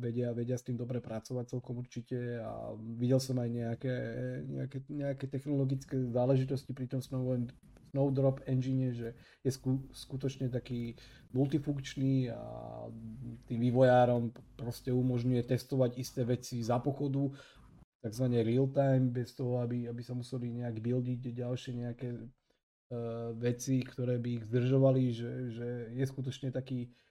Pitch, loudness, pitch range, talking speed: 125 Hz, -35 LUFS, 120-130 Hz, 140 wpm